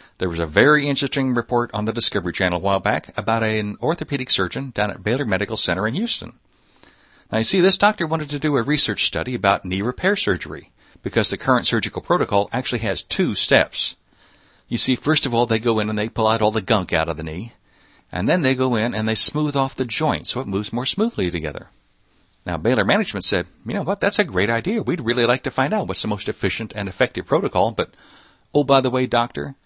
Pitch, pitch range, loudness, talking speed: 115 Hz, 105-135 Hz, -19 LUFS, 230 wpm